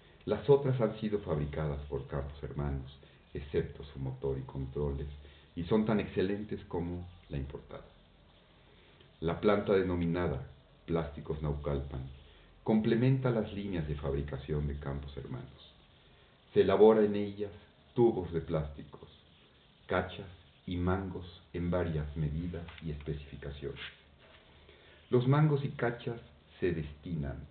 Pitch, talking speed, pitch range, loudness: 80 Hz, 120 wpm, 70-100 Hz, -33 LUFS